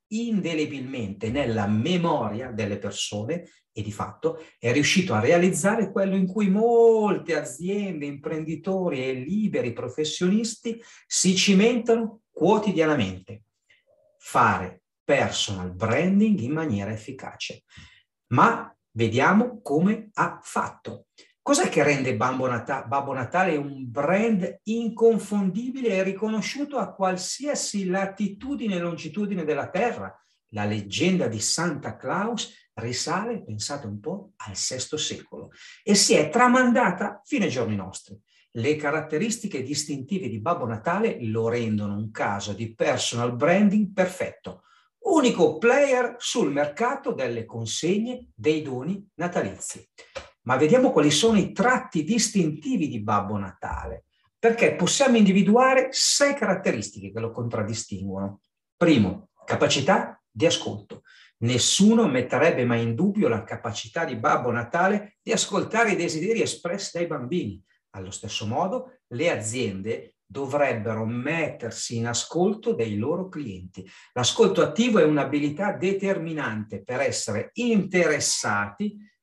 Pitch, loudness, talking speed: 165 Hz, -24 LUFS, 115 wpm